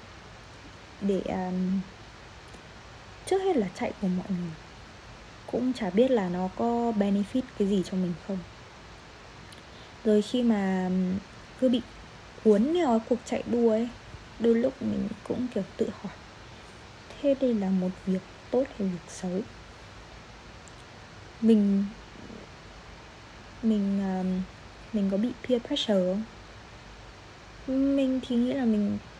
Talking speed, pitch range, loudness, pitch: 130 wpm, 185-240 Hz, -28 LUFS, 205 Hz